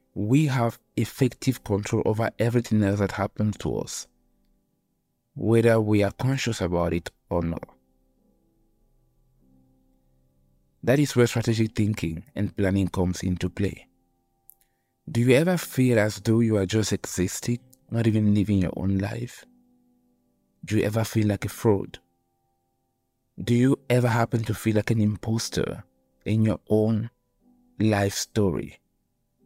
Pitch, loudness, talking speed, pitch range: 105 Hz, -25 LUFS, 135 wpm, 90-120 Hz